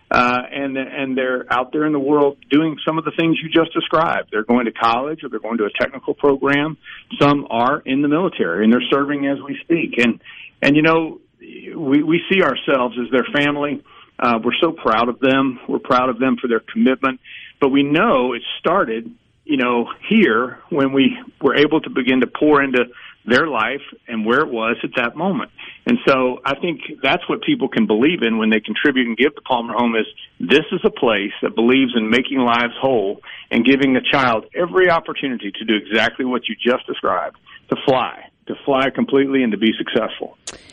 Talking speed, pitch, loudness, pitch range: 205 wpm, 135 Hz, -18 LUFS, 120-145 Hz